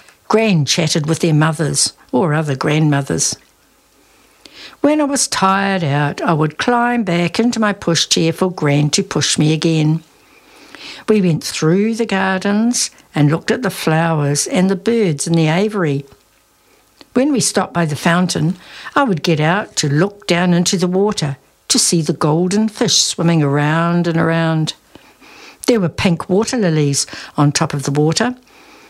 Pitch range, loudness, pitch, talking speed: 155-210 Hz, -15 LUFS, 175 Hz, 160 wpm